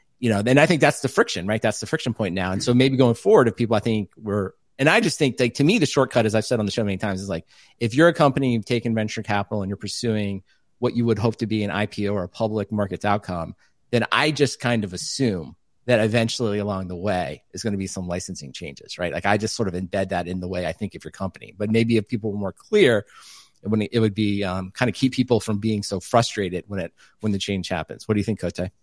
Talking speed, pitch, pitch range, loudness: 275 wpm, 110 Hz, 95-120 Hz, -22 LUFS